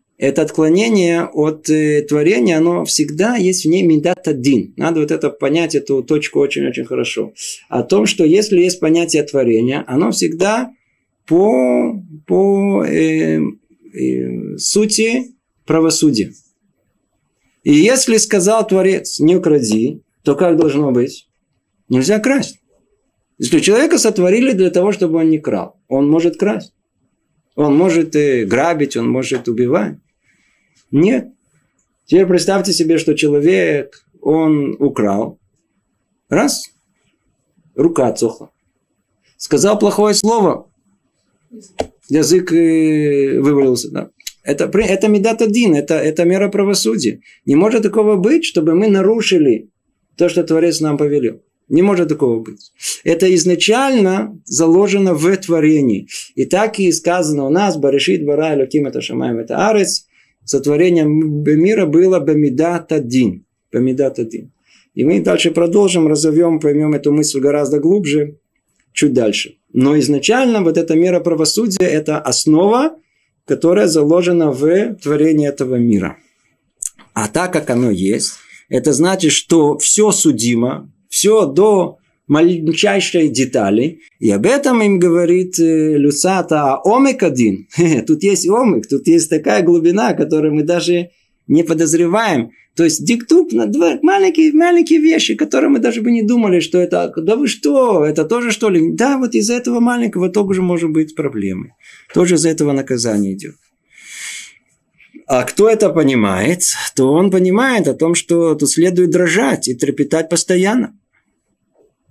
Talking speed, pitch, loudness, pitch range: 130 wpm, 170 Hz, -14 LUFS, 150-200 Hz